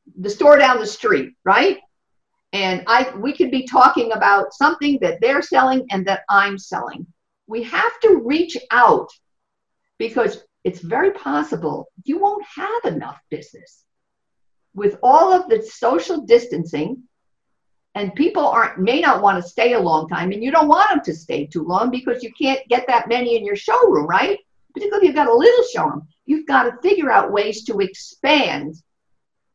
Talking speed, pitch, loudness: 175 wpm, 260 Hz, -17 LUFS